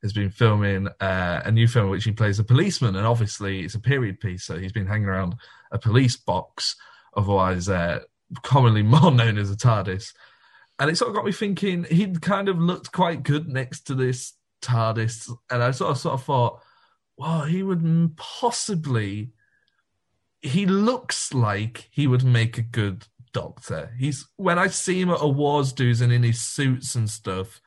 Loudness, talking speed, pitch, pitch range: -23 LUFS, 190 wpm, 125 Hz, 110-150 Hz